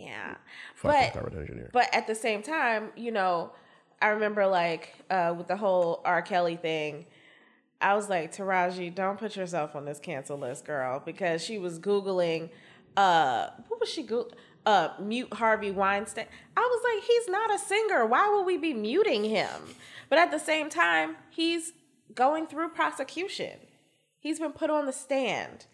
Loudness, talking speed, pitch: -28 LUFS, 170 wpm, 215 Hz